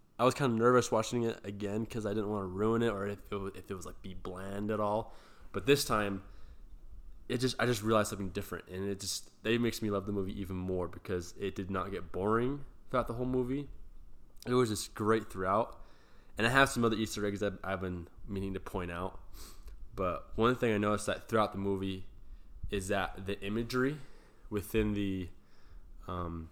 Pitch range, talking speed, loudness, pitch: 95-115 Hz, 210 wpm, -34 LUFS, 100 Hz